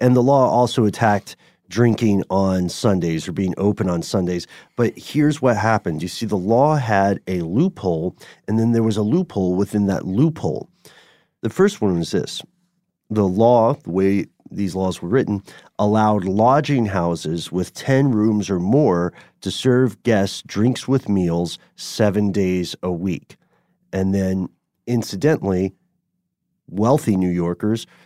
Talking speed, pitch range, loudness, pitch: 150 wpm, 95-125 Hz, -19 LUFS, 105 Hz